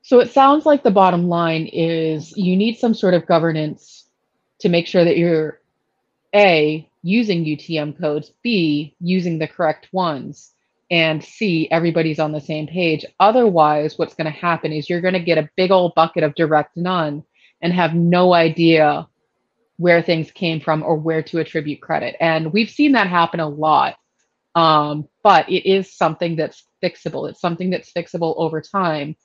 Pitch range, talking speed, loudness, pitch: 155-180 Hz, 170 wpm, -17 LUFS, 165 Hz